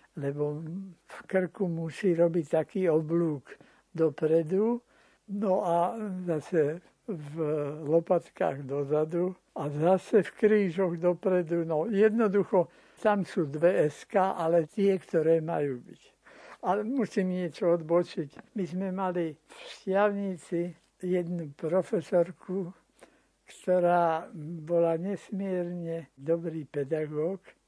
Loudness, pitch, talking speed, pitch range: -29 LUFS, 175 Hz, 100 wpm, 160-190 Hz